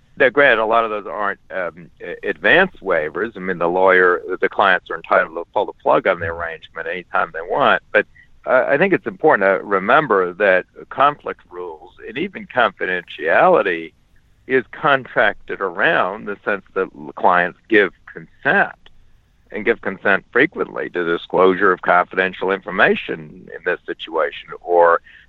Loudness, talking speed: -17 LUFS, 150 wpm